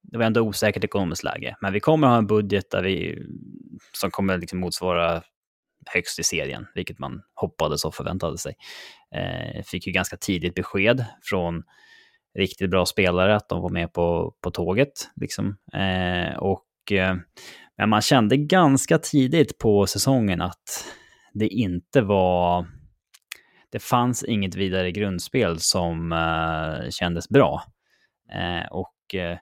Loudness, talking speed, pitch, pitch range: -23 LUFS, 145 wpm, 95 Hz, 90-115 Hz